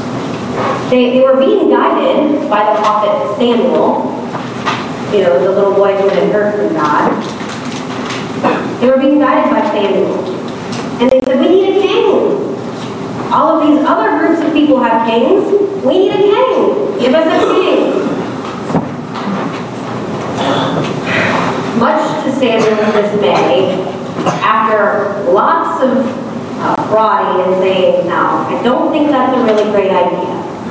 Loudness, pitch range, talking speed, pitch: -12 LUFS, 205-305 Hz, 135 wpm, 255 Hz